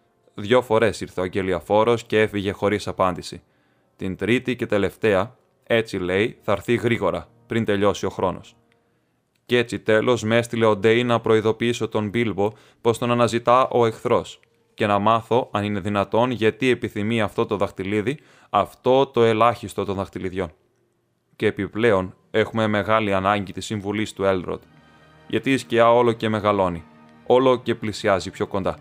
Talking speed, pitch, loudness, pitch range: 155 wpm, 110 Hz, -21 LUFS, 100-115 Hz